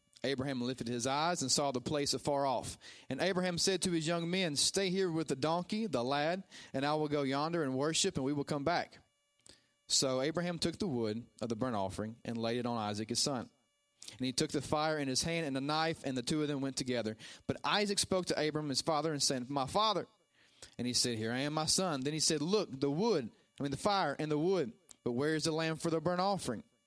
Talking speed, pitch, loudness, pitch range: 250 wpm, 145 Hz, -34 LUFS, 130-165 Hz